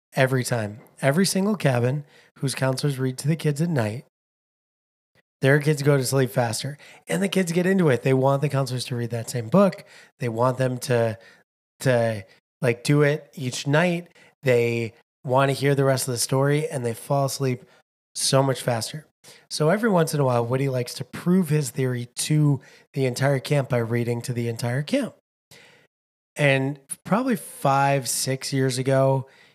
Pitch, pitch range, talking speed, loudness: 135 Hz, 125-150 Hz, 180 wpm, -23 LUFS